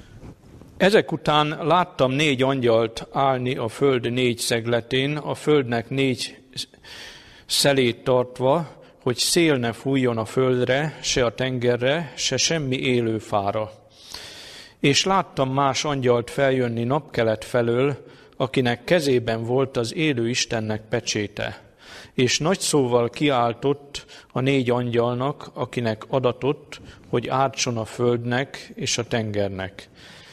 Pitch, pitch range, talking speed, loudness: 125 Hz, 120-140 Hz, 115 wpm, -22 LUFS